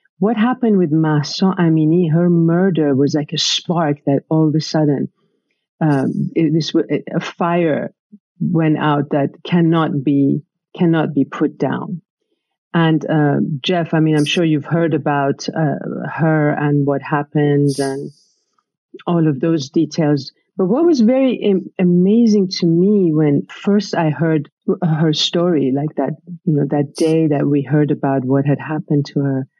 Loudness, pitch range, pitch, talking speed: -16 LUFS, 145-175 Hz, 160 Hz, 160 wpm